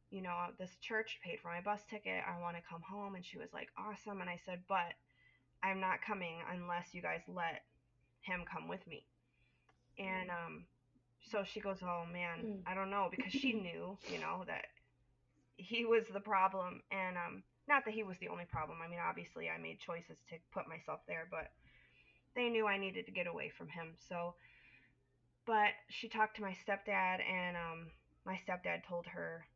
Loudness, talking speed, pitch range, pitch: -41 LUFS, 195 wpm, 170-205 Hz, 185 Hz